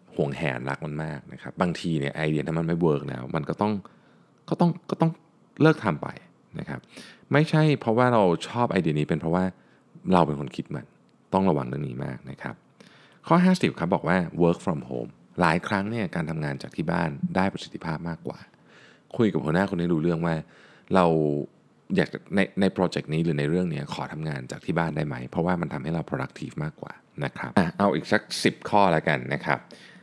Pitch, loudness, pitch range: 85 Hz, -26 LUFS, 75-125 Hz